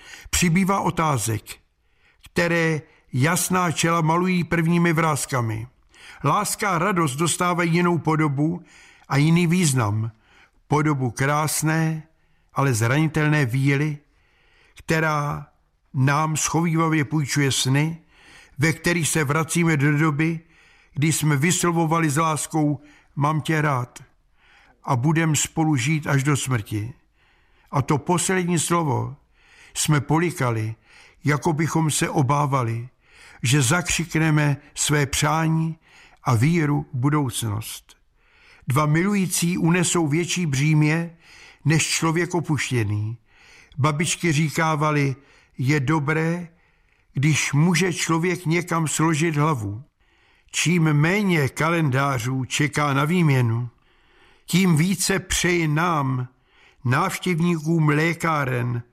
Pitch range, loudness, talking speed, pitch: 140-165 Hz, -21 LUFS, 100 wpm, 155 Hz